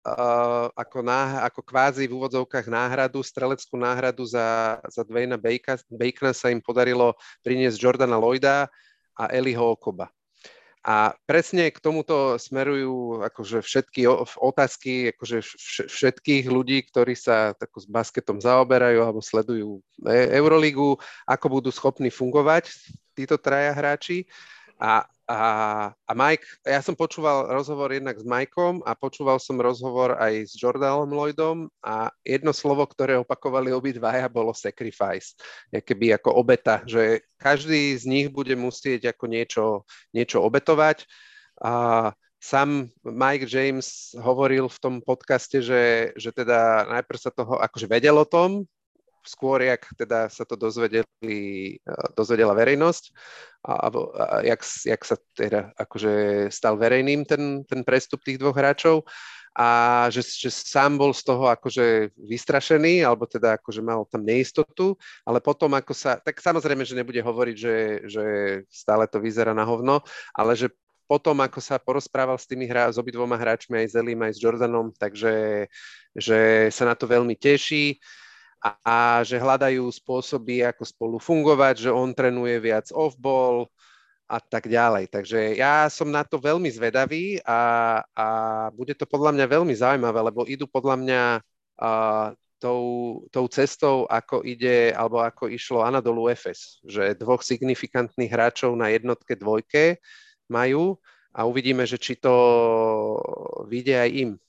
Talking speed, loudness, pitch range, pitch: 145 wpm, -23 LUFS, 115-135 Hz, 125 Hz